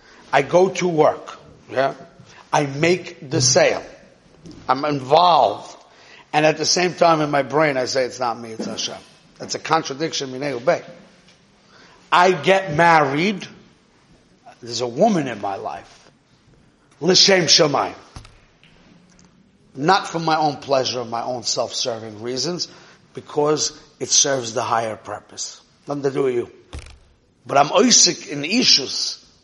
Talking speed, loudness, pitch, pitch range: 140 wpm, -18 LUFS, 155 Hz, 140-180 Hz